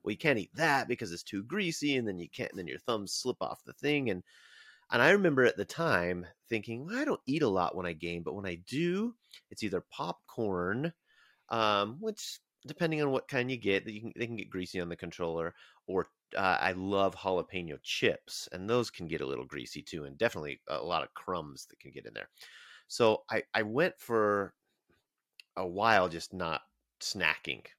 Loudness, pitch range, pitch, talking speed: -33 LUFS, 90-125 Hz, 100 Hz, 210 wpm